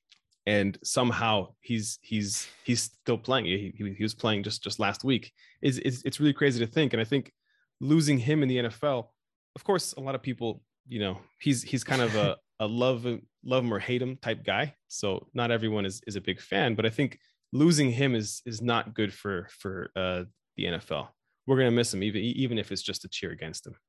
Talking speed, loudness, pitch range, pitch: 225 wpm, -29 LUFS, 105-130 Hz, 120 Hz